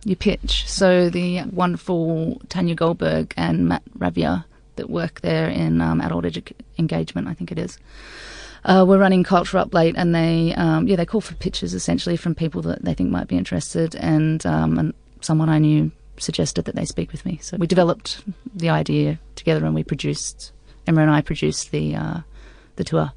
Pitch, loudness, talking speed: 160 Hz, -21 LUFS, 190 wpm